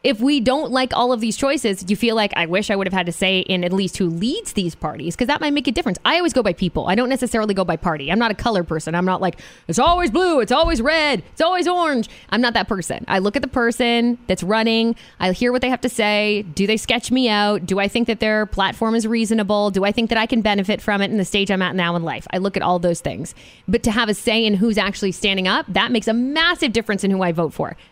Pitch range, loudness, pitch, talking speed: 190-245 Hz, -19 LUFS, 215 Hz, 290 wpm